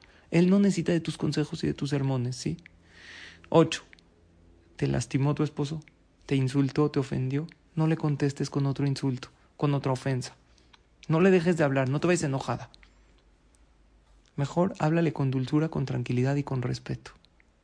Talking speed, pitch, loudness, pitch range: 160 wpm, 140 Hz, -28 LUFS, 125-155 Hz